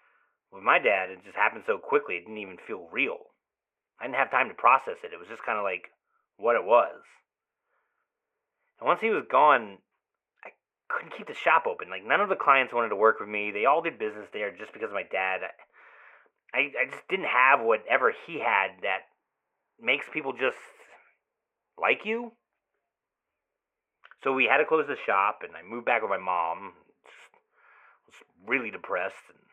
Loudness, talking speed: -26 LUFS, 190 wpm